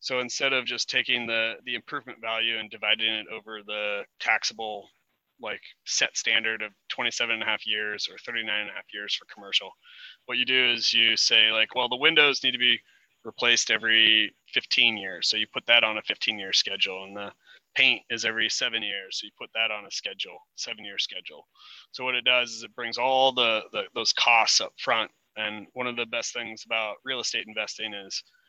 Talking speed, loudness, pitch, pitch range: 210 wpm, -24 LUFS, 115 Hz, 110-125 Hz